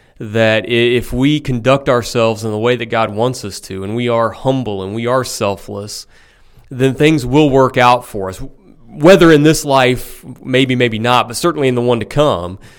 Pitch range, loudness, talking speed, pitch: 110-135 Hz, -13 LUFS, 195 wpm, 125 Hz